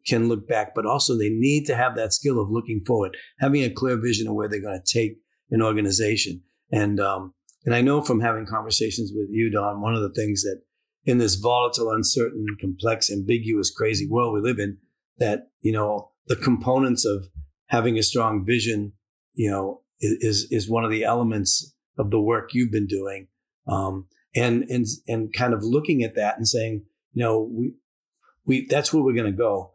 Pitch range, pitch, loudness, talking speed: 105-120 Hz, 110 Hz, -23 LUFS, 200 wpm